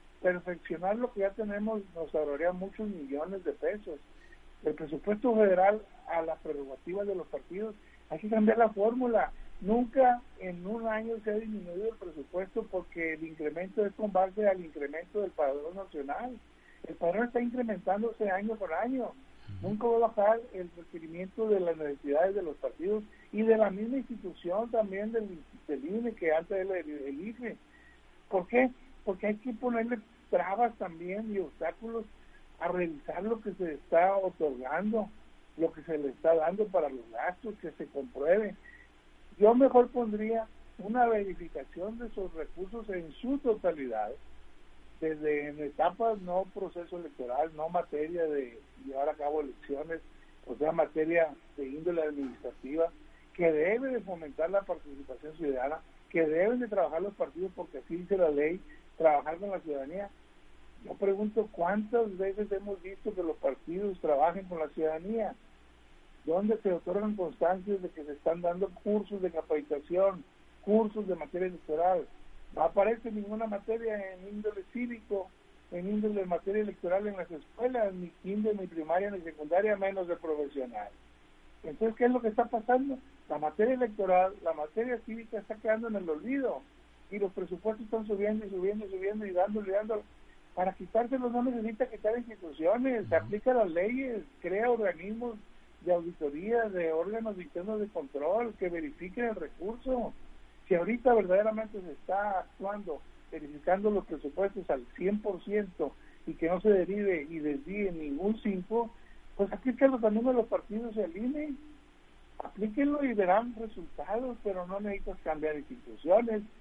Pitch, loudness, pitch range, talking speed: 195 Hz, -32 LUFS, 165-220 Hz, 155 wpm